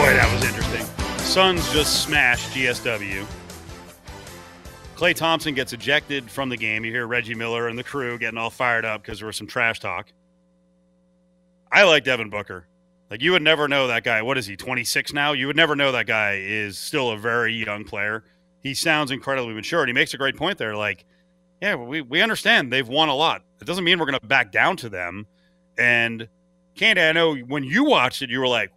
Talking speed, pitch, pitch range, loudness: 215 wpm, 120 Hz, 100-140 Hz, -21 LUFS